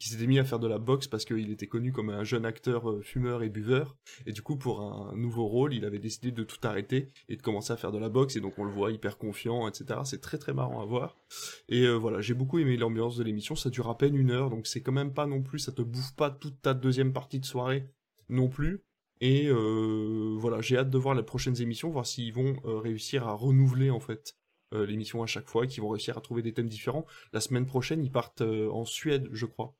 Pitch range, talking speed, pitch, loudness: 110-130 Hz, 265 wpm, 120 Hz, -31 LUFS